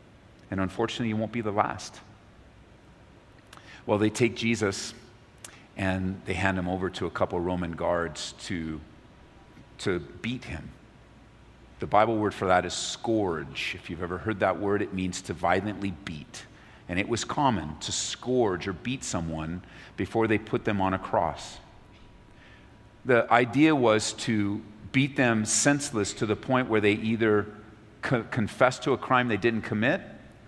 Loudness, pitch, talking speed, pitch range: -27 LUFS, 105 Hz, 160 wpm, 95-115 Hz